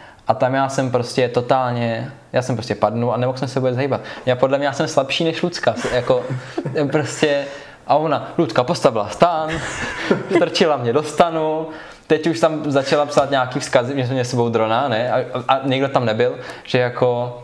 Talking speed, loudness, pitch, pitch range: 195 wpm, -19 LUFS, 135 Hz, 125-150 Hz